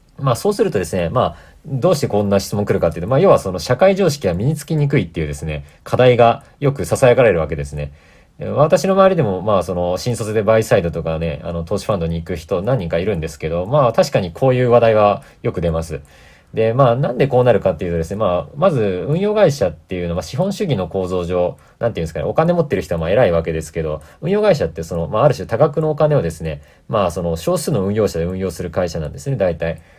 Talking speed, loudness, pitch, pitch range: 490 characters per minute, -17 LUFS, 100 Hz, 85-140 Hz